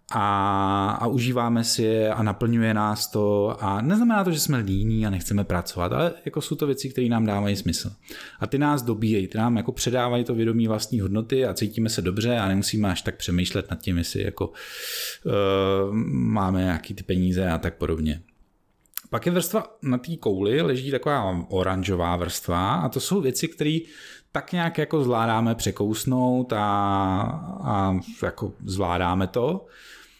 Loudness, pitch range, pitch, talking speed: -24 LUFS, 95-130 Hz, 110 Hz, 170 wpm